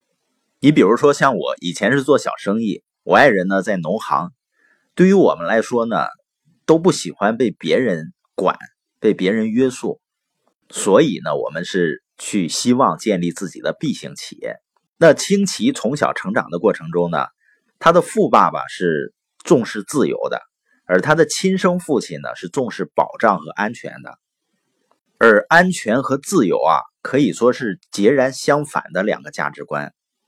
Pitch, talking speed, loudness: 130 Hz, 235 characters per minute, -17 LUFS